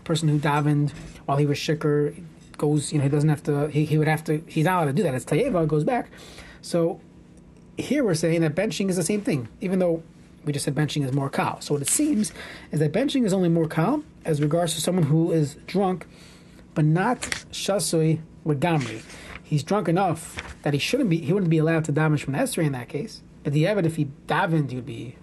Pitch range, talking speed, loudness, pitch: 150-175 Hz, 235 wpm, -24 LUFS, 160 Hz